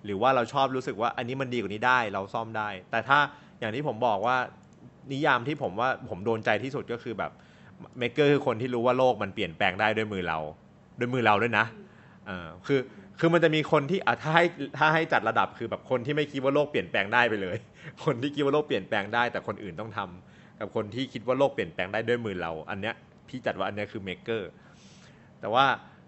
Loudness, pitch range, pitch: -27 LUFS, 105-140 Hz, 120 Hz